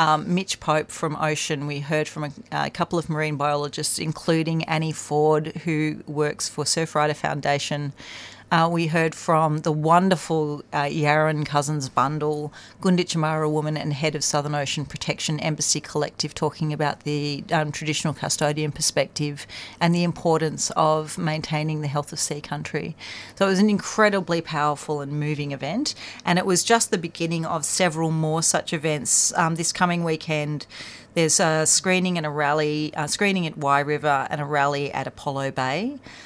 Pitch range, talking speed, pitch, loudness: 150-165 Hz, 165 wpm, 155 Hz, -23 LUFS